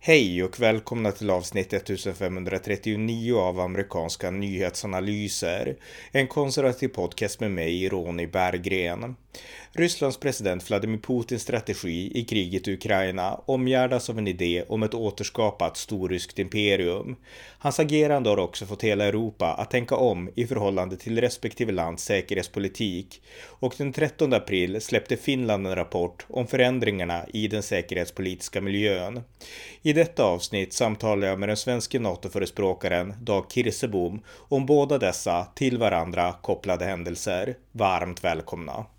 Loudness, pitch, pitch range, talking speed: -26 LUFS, 105 Hz, 95-120 Hz, 130 wpm